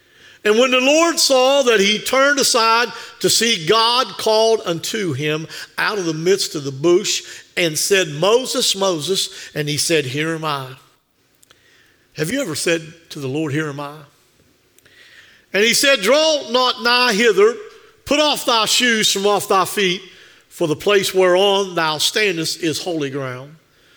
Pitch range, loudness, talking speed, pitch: 160-240 Hz, -16 LUFS, 165 wpm, 195 Hz